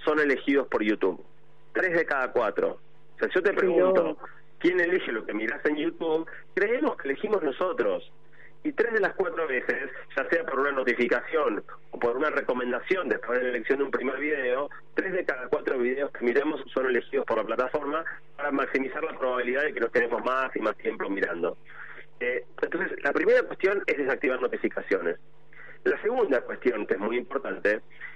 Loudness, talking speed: -27 LUFS, 185 wpm